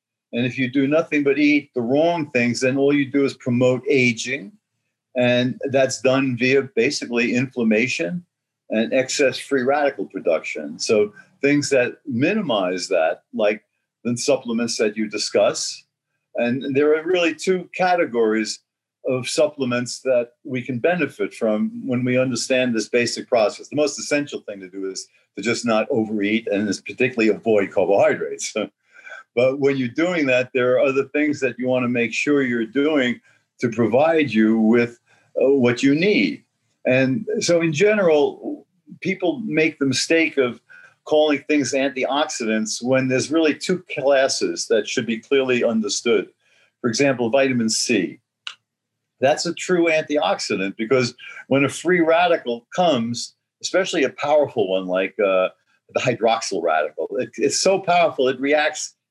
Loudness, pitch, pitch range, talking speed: -20 LUFS, 135 Hz, 120-155 Hz, 150 wpm